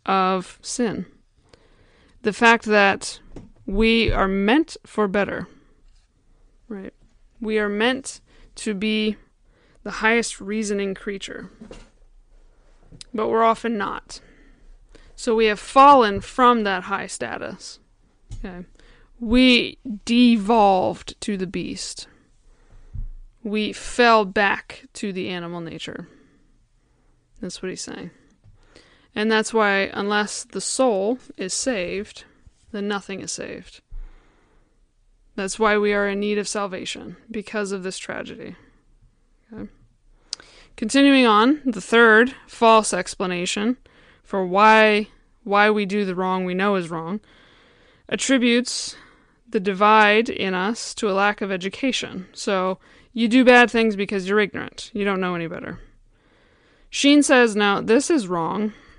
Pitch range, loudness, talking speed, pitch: 190-230 Hz, -20 LUFS, 120 wpm, 210 Hz